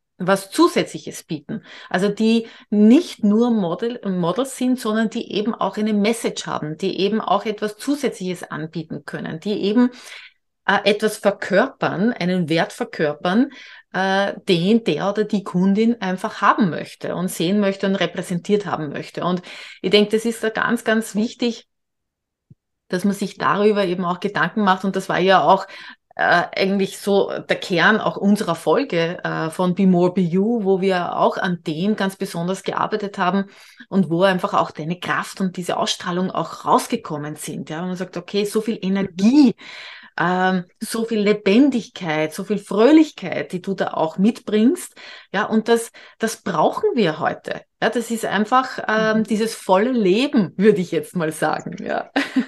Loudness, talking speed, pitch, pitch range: -20 LUFS, 165 wpm, 200 Hz, 185-220 Hz